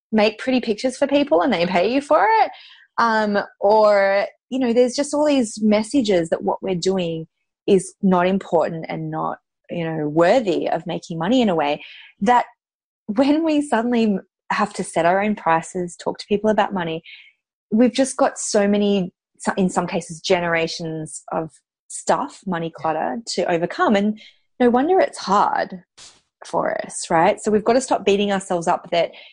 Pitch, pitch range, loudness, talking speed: 200 Hz, 175-235 Hz, -20 LUFS, 175 wpm